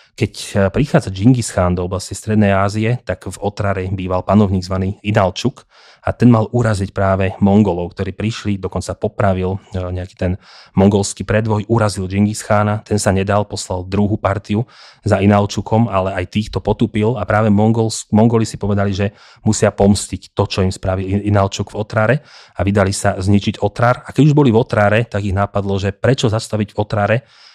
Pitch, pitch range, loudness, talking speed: 105 Hz, 95-110 Hz, -16 LUFS, 170 wpm